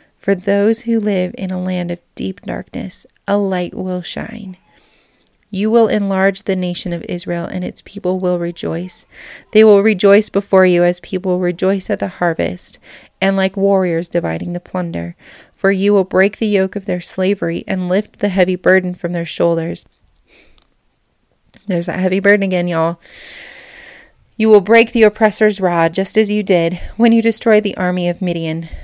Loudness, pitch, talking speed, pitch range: -15 LUFS, 190 Hz, 175 wpm, 175-210 Hz